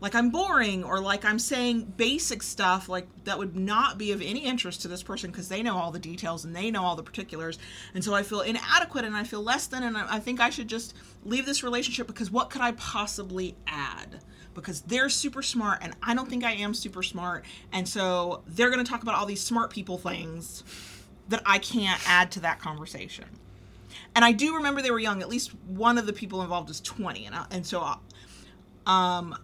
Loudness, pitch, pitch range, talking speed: -28 LUFS, 205 Hz, 180-235 Hz, 225 wpm